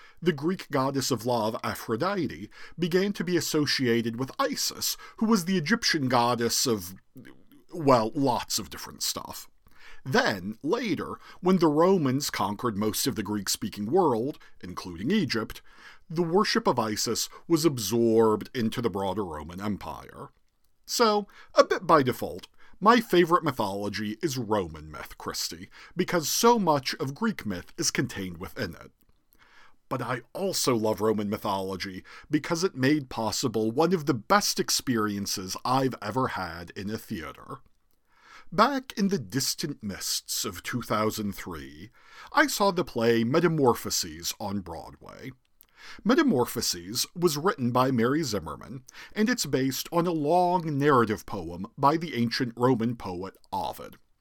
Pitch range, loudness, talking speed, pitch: 105-175 Hz, -27 LUFS, 140 wpm, 130 Hz